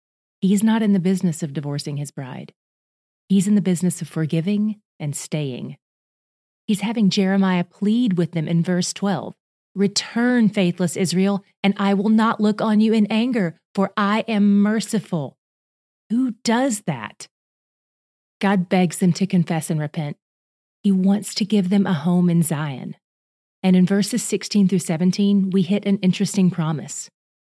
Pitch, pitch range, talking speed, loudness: 190 Hz, 170-205 Hz, 155 wpm, -20 LUFS